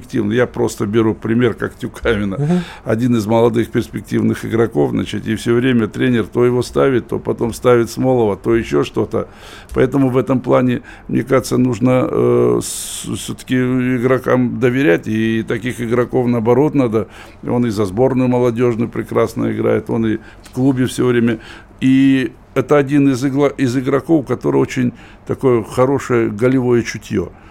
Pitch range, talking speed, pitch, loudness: 115-130 Hz, 150 wpm, 120 Hz, -16 LUFS